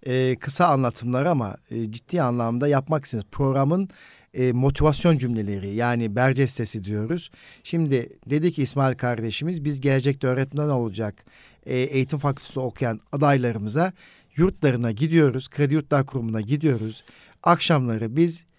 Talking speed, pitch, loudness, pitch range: 125 wpm, 135 Hz, -23 LUFS, 120-150 Hz